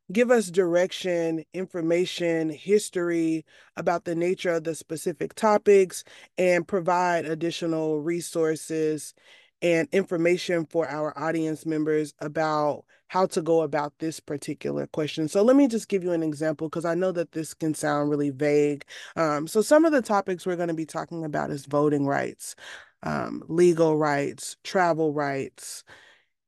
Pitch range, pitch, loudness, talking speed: 155-180 Hz, 165 Hz, -25 LUFS, 150 wpm